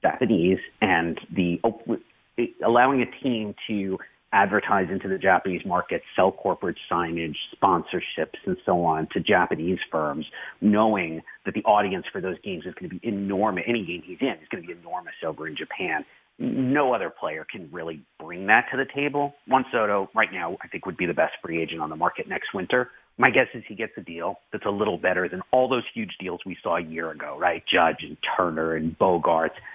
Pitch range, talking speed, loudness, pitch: 85-120 Hz, 200 wpm, -25 LUFS, 100 Hz